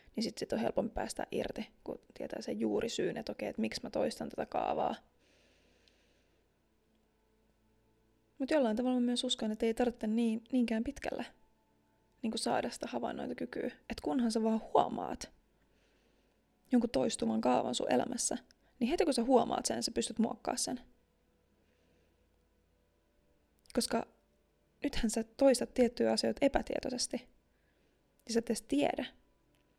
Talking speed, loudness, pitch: 135 wpm, -34 LUFS, 225 Hz